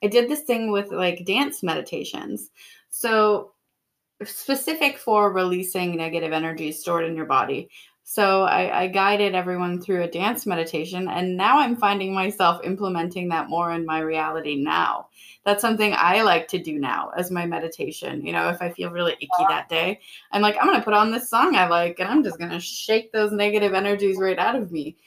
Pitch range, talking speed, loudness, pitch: 170-210 Hz, 195 wpm, -22 LUFS, 185 Hz